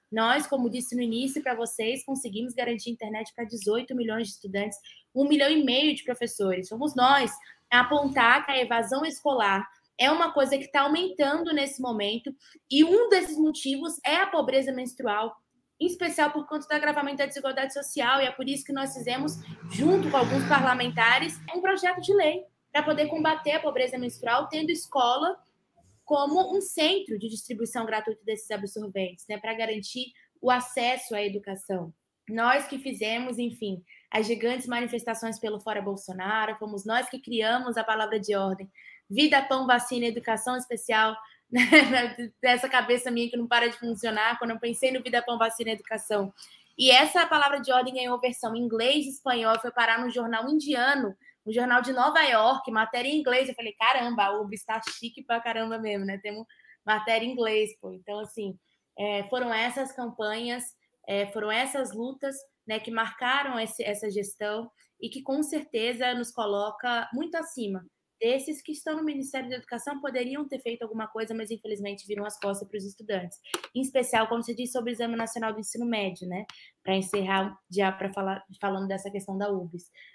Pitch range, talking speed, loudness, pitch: 220-270 Hz, 180 wpm, -27 LUFS, 240 Hz